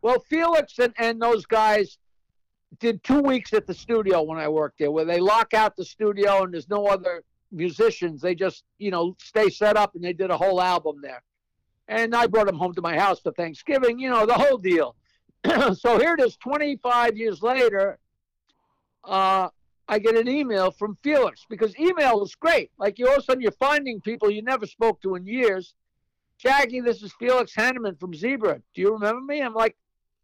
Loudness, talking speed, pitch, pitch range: -23 LUFS, 200 wpm, 215 Hz, 185-240 Hz